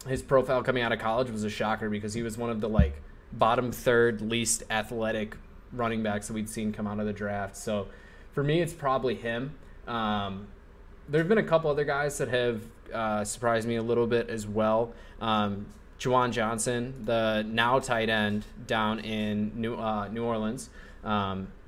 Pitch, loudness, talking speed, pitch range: 110 Hz, -29 LUFS, 185 wpm, 105-120 Hz